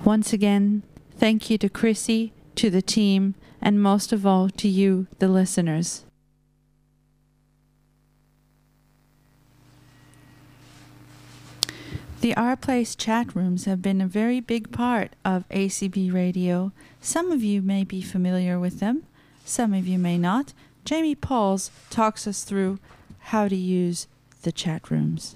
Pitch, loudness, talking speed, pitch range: 195 Hz, -24 LUFS, 130 wpm, 180-220 Hz